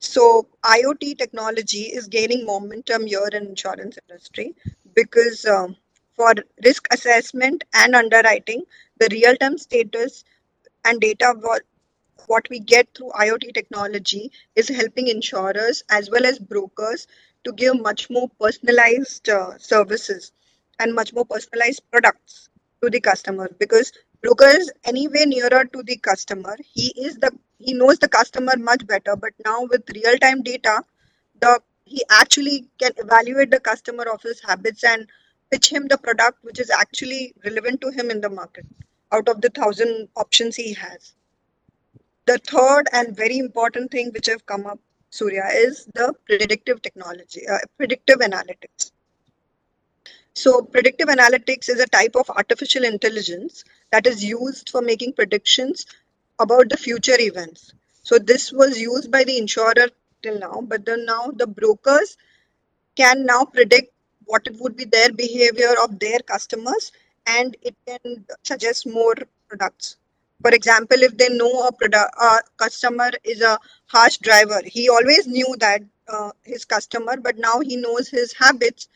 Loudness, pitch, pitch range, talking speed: -17 LUFS, 240 Hz, 220-255 Hz, 150 wpm